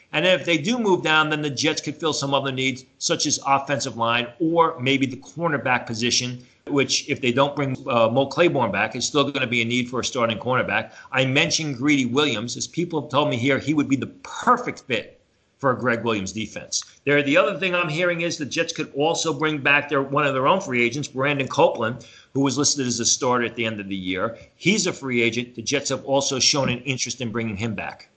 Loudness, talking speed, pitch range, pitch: -22 LUFS, 240 wpm, 120-150 Hz, 135 Hz